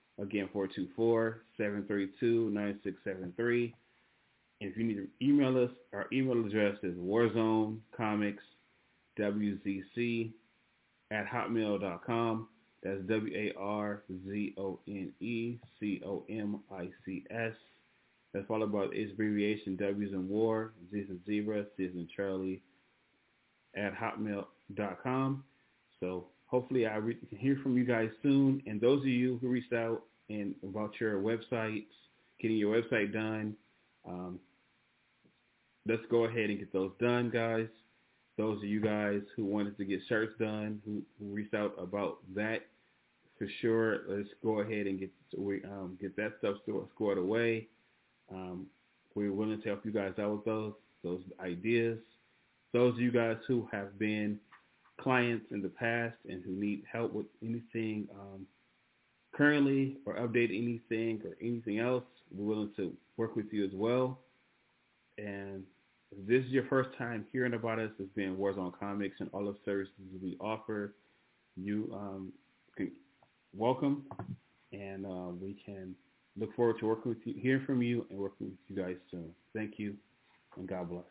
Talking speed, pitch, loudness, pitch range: 140 wpm, 105 Hz, -35 LUFS, 100-115 Hz